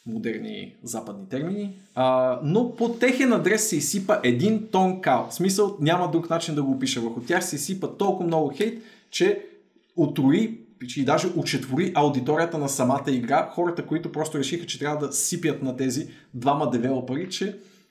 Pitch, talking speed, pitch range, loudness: 160 Hz, 165 wpm, 135-200 Hz, -24 LUFS